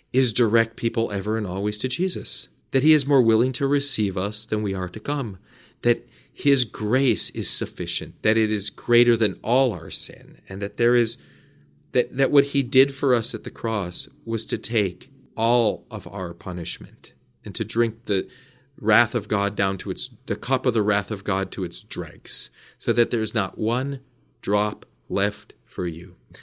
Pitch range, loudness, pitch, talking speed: 100-125 Hz, -21 LUFS, 115 Hz, 195 wpm